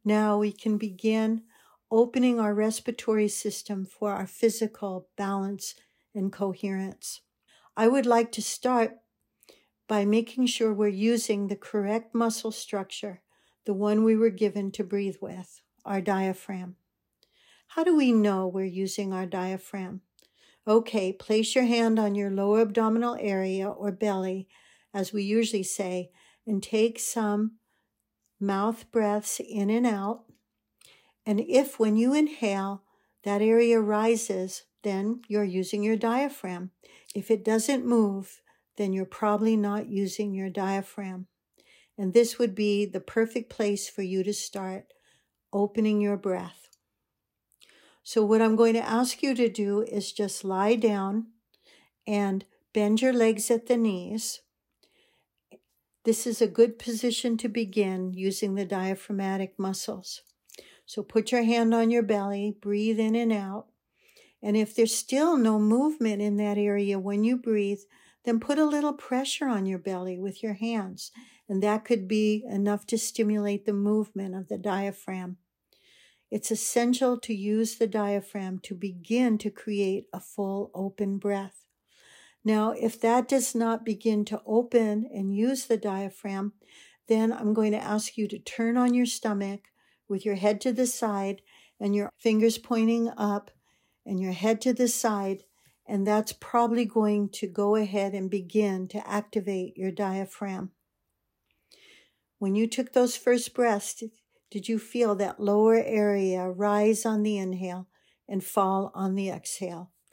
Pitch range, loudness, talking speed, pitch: 195-230 Hz, -27 LUFS, 150 wpm, 210 Hz